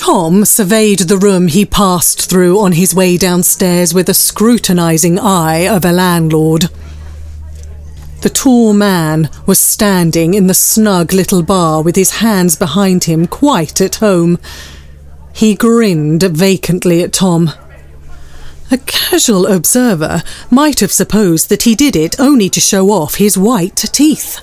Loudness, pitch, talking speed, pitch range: -9 LUFS, 185 Hz, 140 wpm, 165-205 Hz